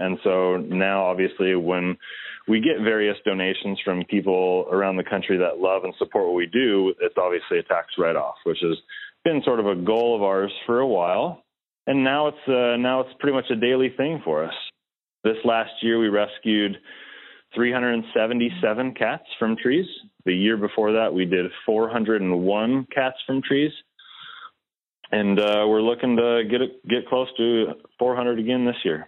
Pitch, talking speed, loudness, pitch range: 115 Hz, 175 wpm, -22 LUFS, 100-130 Hz